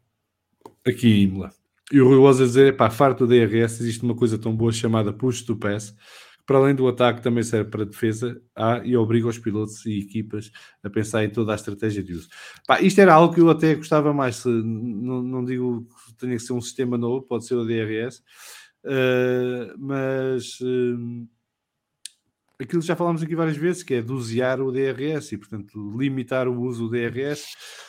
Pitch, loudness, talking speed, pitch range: 120 Hz, -21 LUFS, 200 wpm, 110-130 Hz